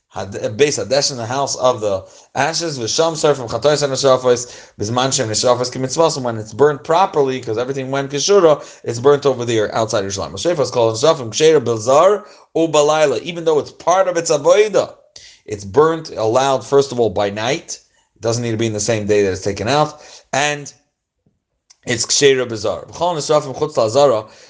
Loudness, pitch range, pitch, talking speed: -16 LUFS, 115-150 Hz, 130 Hz, 150 wpm